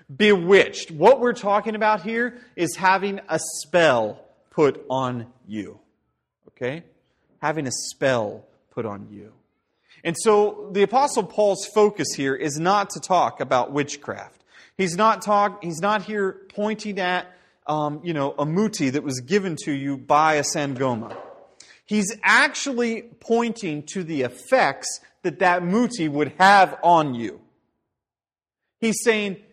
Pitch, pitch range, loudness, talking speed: 180 Hz, 150-210 Hz, -22 LUFS, 140 wpm